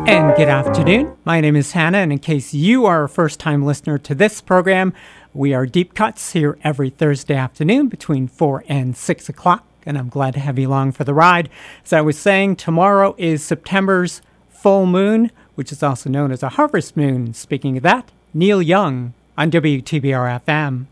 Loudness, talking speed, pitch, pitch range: -16 LUFS, 185 wpm, 155 Hz, 140-185 Hz